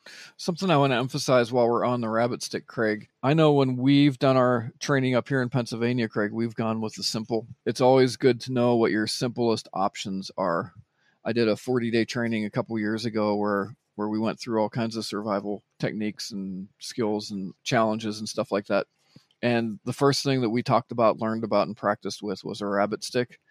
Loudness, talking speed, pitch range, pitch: -26 LUFS, 215 wpm, 105-125 Hz, 115 Hz